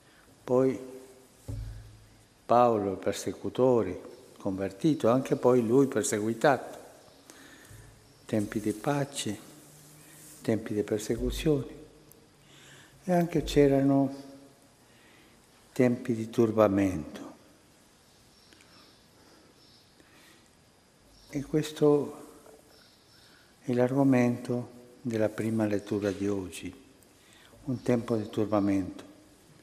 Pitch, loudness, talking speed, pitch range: 125 Hz, -28 LUFS, 70 wpm, 110-140 Hz